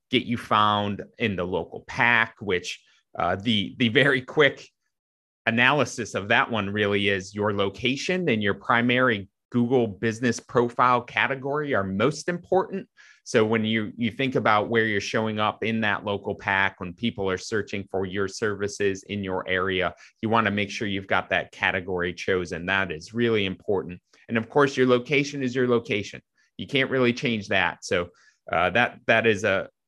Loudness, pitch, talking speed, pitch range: -24 LUFS, 110 Hz, 175 wpm, 100-125 Hz